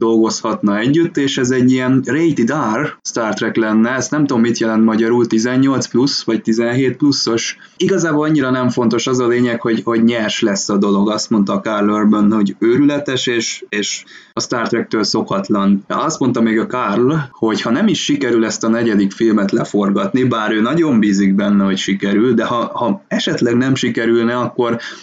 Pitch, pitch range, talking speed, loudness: 115 Hz, 110-130 Hz, 185 wpm, -15 LUFS